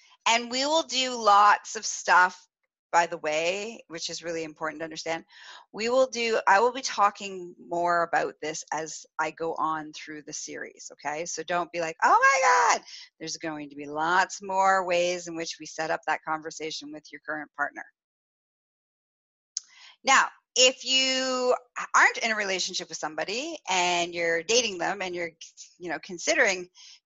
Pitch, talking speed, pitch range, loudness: 175 Hz, 170 wpm, 160-230 Hz, -25 LUFS